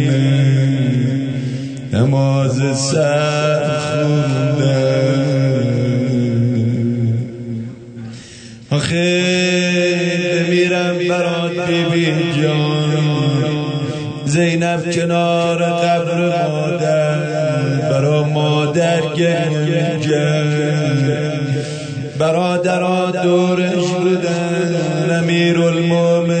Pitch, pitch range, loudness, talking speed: 150 Hz, 135-170 Hz, -16 LUFS, 45 wpm